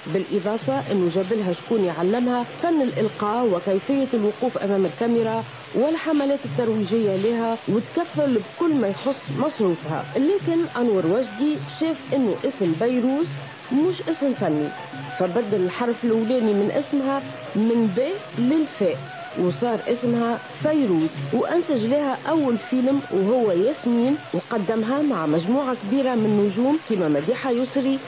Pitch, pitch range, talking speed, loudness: 235 Hz, 200-275 Hz, 120 wpm, -23 LUFS